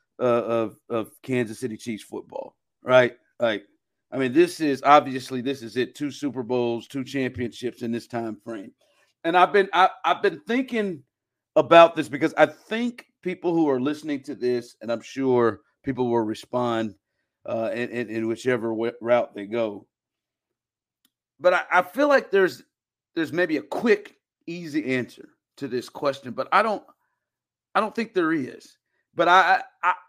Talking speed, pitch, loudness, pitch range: 170 wpm, 130 Hz, -23 LUFS, 120-170 Hz